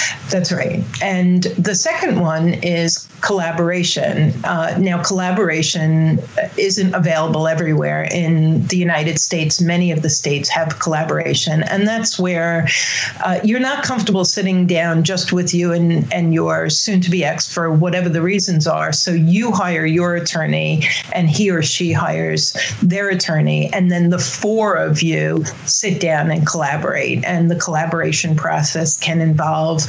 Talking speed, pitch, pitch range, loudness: 155 wpm, 170 Hz, 160-180 Hz, -16 LUFS